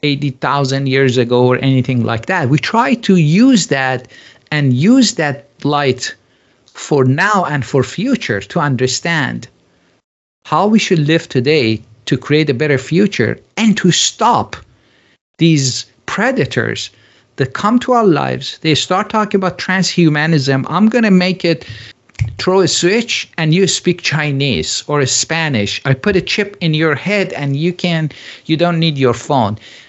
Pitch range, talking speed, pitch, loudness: 130-180 Hz, 155 wpm, 150 Hz, -14 LUFS